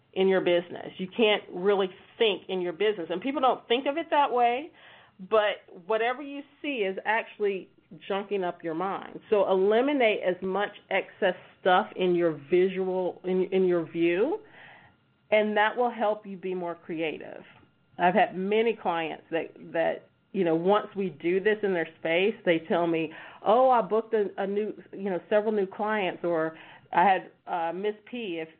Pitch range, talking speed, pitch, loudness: 175-215 Hz, 180 wpm, 195 Hz, -27 LUFS